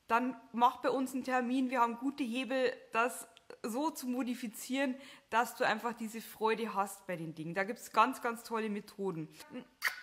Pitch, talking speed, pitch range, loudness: 235 Hz, 180 wpm, 225-255 Hz, -35 LUFS